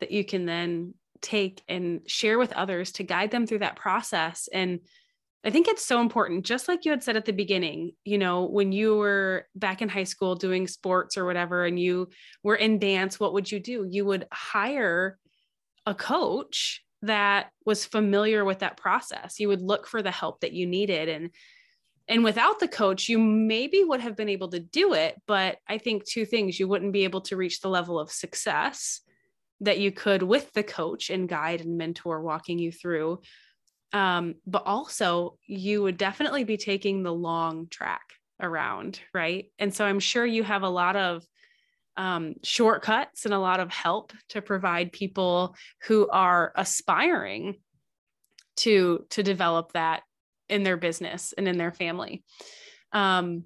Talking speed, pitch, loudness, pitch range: 180 wpm, 195 Hz, -26 LUFS, 180-215 Hz